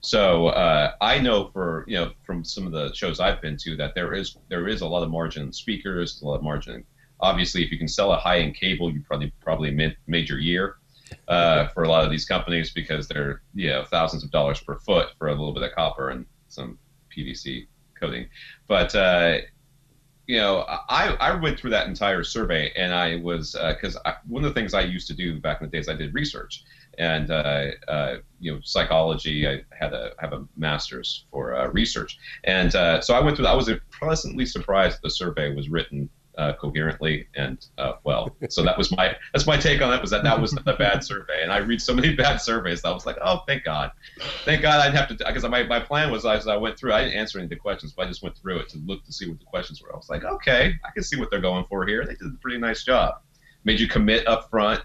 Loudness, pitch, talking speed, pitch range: -24 LUFS, 85 Hz, 245 wpm, 75-110 Hz